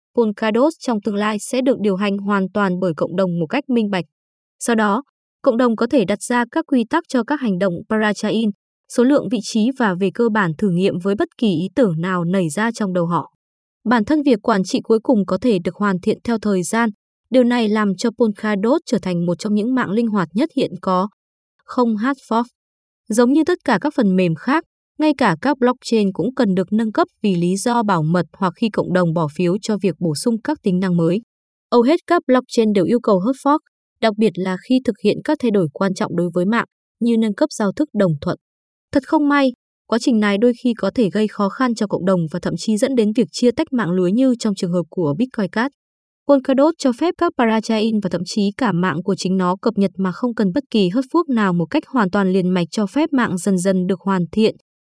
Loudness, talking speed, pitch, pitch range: -18 LUFS, 245 wpm, 220 Hz, 190-250 Hz